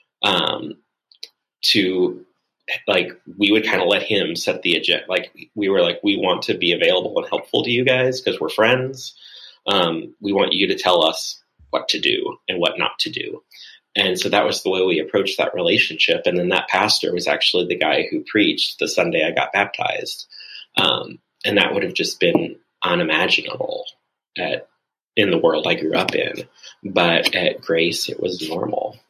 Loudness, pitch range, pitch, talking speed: -19 LUFS, 325-500 Hz, 390 Hz, 190 wpm